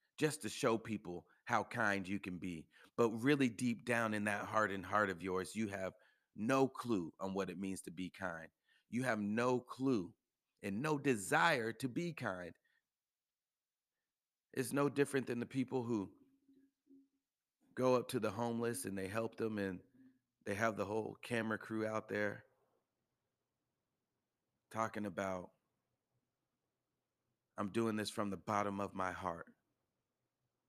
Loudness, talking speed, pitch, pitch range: -39 LUFS, 150 wpm, 110 Hz, 100-130 Hz